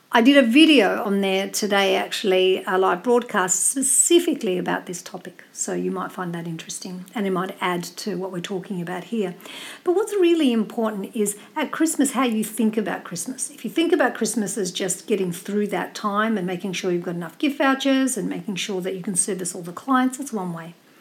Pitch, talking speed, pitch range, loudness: 205 Hz, 215 wpm, 185-250 Hz, -22 LUFS